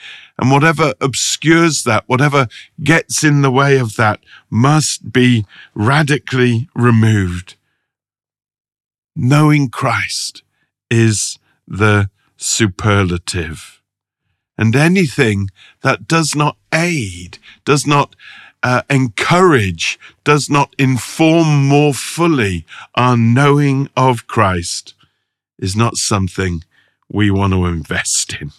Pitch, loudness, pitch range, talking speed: 125 Hz, -14 LUFS, 105-145 Hz, 100 wpm